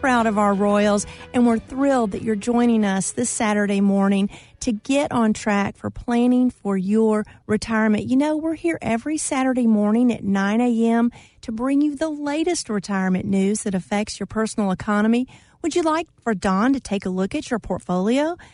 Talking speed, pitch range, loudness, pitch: 185 wpm, 205-250 Hz, -21 LUFS, 225 Hz